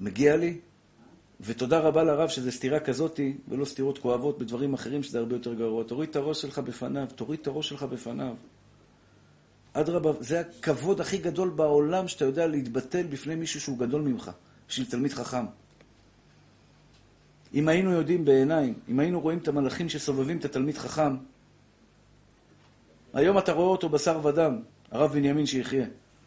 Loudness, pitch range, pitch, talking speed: -28 LUFS, 130-160 Hz, 145 Hz, 150 wpm